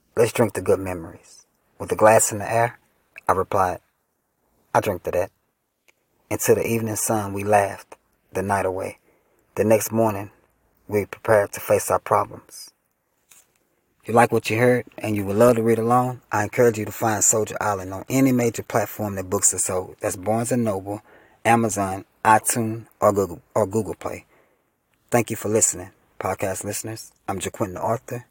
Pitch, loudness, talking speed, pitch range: 105 Hz, -22 LUFS, 175 wpm, 100-115 Hz